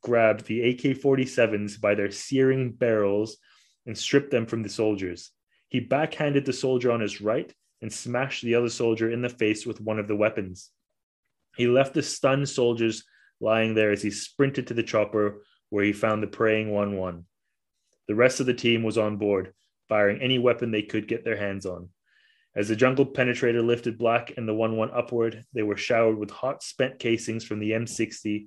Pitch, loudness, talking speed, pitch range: 115 Hz, -25 LUFS, 195 wpm, 105-125 Hz